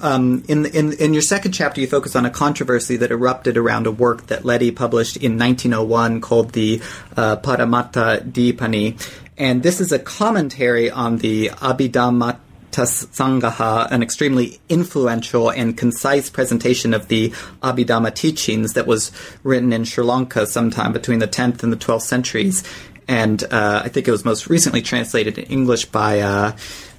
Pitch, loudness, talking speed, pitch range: 120 Hz, -18 LUFS, 160 wpm, 115-130 Hz